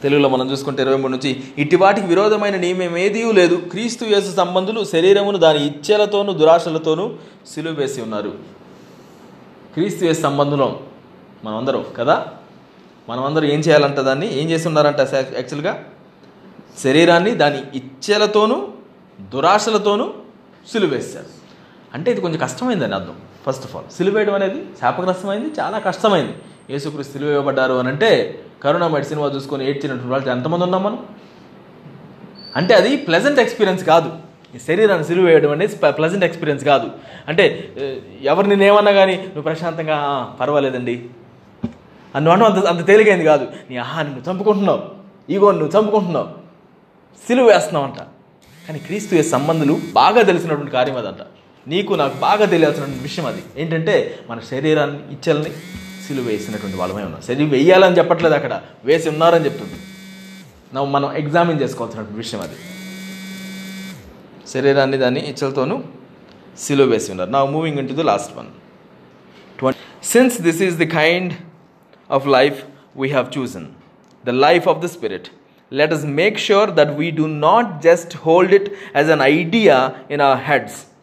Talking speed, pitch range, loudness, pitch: 115 wpm, 140-190 Hz, -17 LUFS, 160 Hz